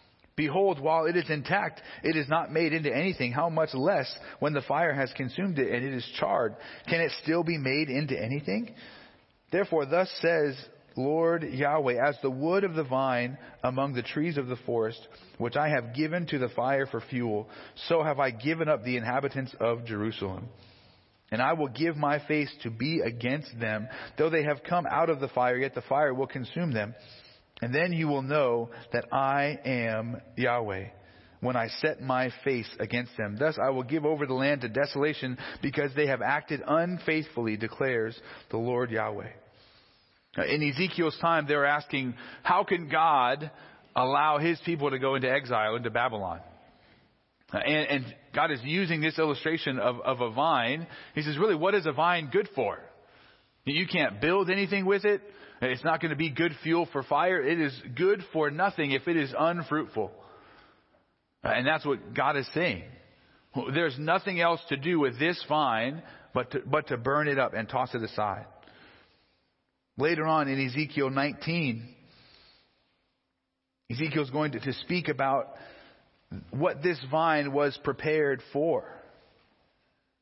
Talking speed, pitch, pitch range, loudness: 170 wpm, 140 Hz, 125-160 Hz, -29 LUFS